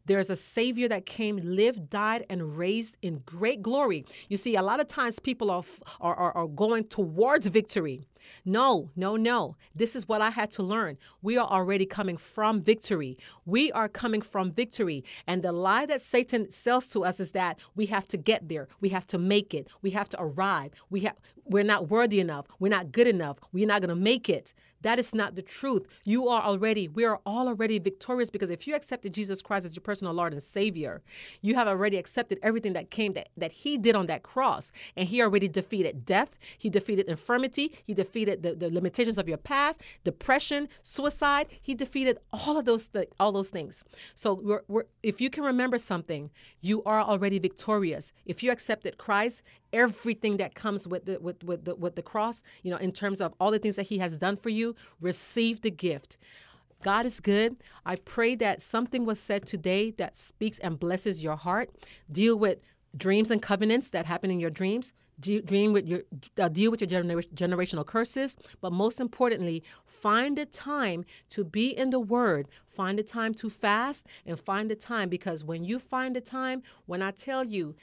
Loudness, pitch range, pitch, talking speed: -29 LUFS, 185-230 Hz, 205 Hz, 205 wpm